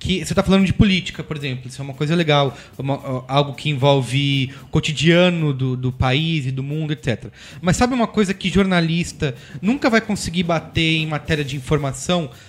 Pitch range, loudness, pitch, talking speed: 135-175 Hz, -19 LUFS, 150 Hz, 190 wpm